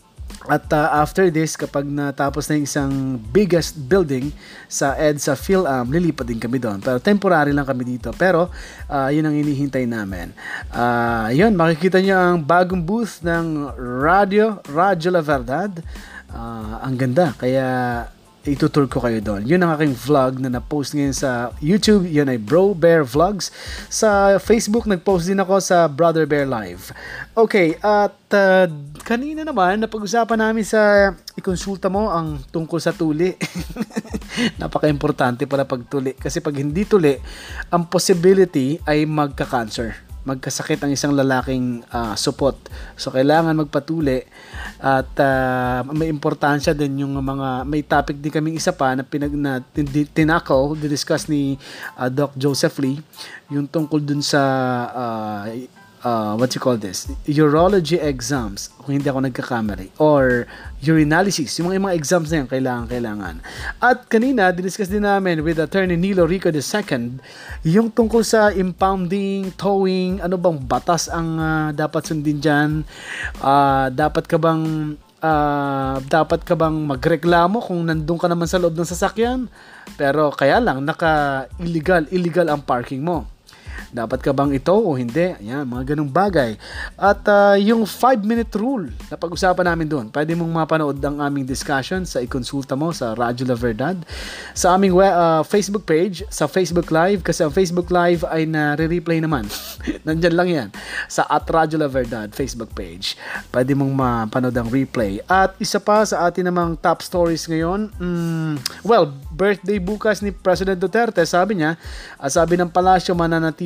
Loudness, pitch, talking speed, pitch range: -19 LUFS, 155 Hz, 155 wpm, 135-180 Hz